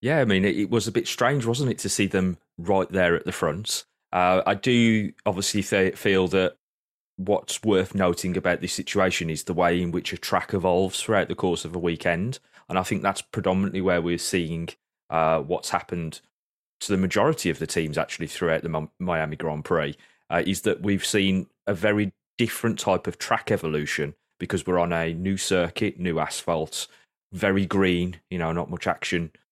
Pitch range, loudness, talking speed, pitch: 85-100 Hz, -25 LUFS, 195 wpm, 95 Hz